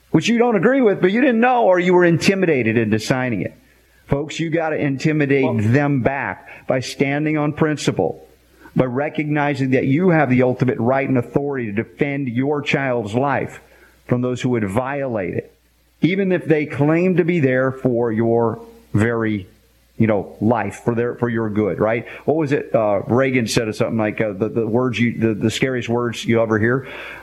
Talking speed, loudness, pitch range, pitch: 190 wpm, -19 LUFS, 115-150 Hz, 130 Hz